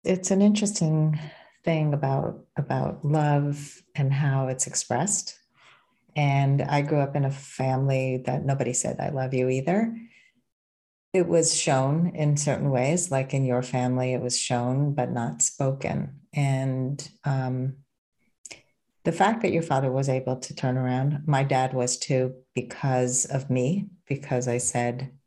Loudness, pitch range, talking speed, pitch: -25 LUFS, 130-155 Hz, 150 wpm, 135 Hz